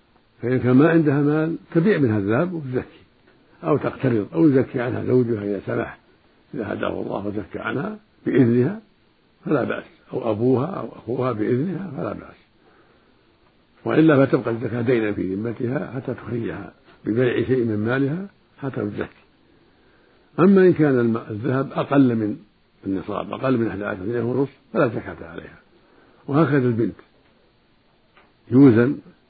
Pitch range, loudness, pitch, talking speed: 110-140 Hz, -21 LUFS, 125 Hz, 130 wpm